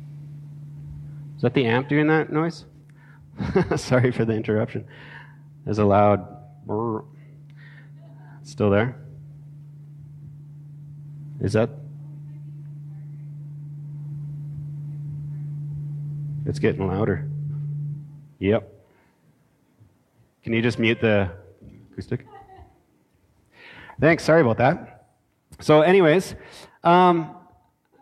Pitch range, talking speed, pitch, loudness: 125-145 Hz, 75 wpm, 145 Hz, -22 LUFS